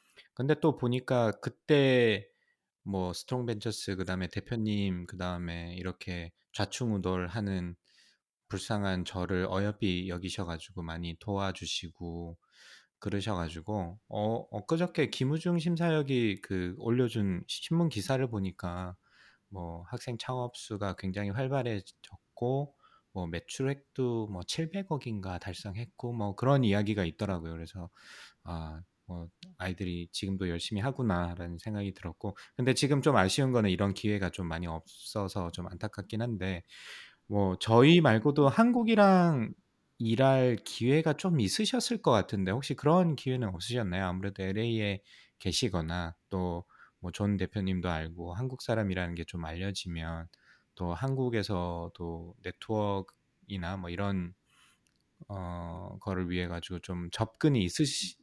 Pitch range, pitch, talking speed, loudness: 90-125 Hz, 100 Hz, 285 characters per minute, -32 LUFS